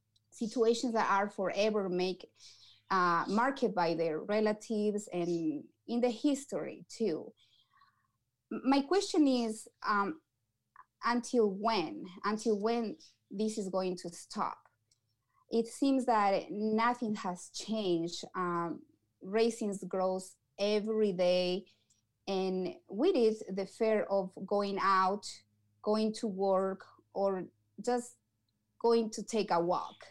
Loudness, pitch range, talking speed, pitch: -33 LUFS, 180-230 Hz, 115 wpm, 205 Hz